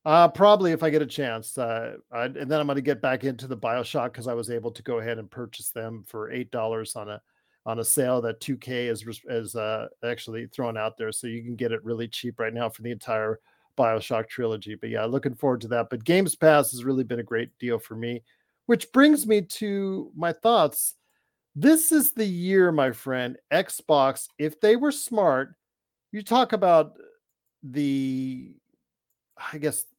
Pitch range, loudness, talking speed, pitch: 115-160 Hz, -25 LUFS, 200 wpm, 125 Hz